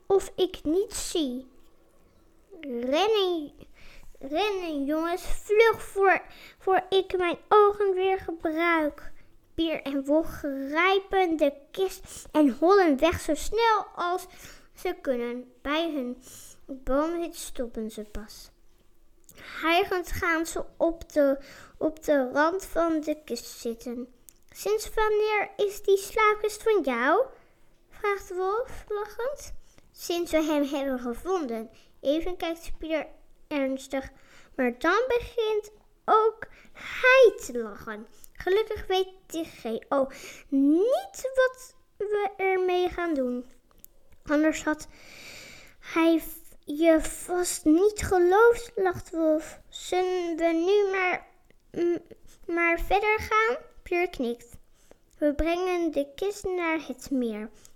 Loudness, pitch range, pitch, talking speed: -26 LUFS, 290-390 Hz, 340 Hz, 115 wpm